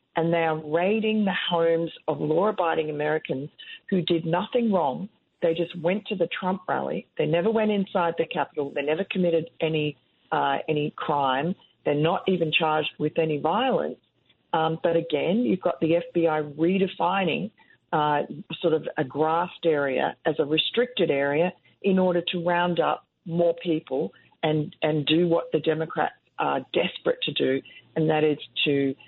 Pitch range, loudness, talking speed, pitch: 155-180 Hz, -25 LUFS, 165 wpm, 165 Hz